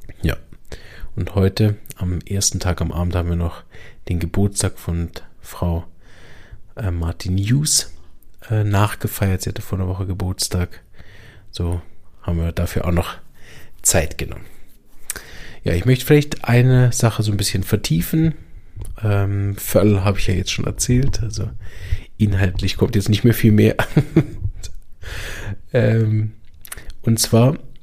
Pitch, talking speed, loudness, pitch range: 100 Hz, 135 wpm, -19 LUFS, 90-110 Hz